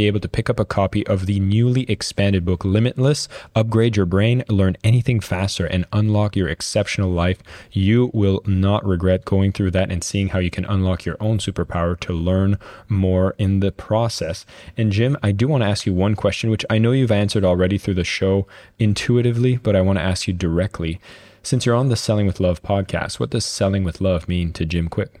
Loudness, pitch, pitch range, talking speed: -20 LUFS, 100 Hz, 95-110 Hz, 210 wpm